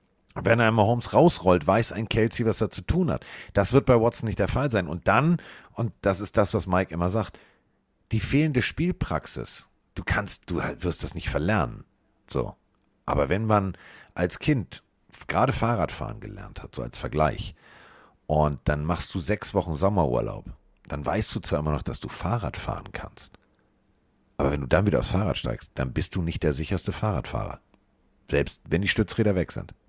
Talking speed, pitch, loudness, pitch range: 190 wpm, 100 Hz, -26 LUFS, 85-110 Hz